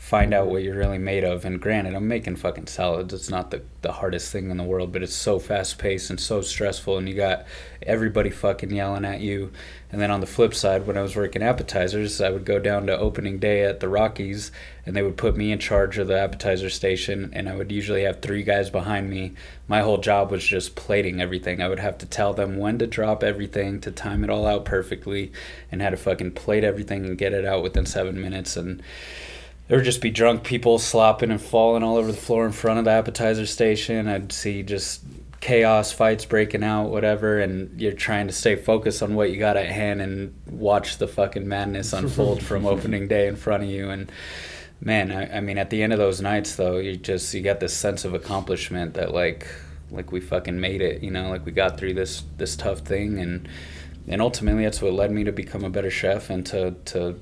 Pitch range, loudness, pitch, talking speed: 95-105 Hz, -24 LUFS, 100 Hz, 230 wpm